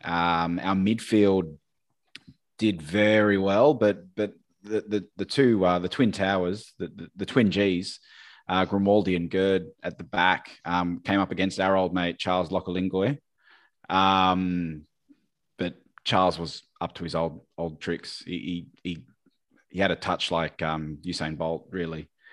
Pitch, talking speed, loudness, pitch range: 95 Hz, 155 wpm, -26 LUFS, 85-100 Hz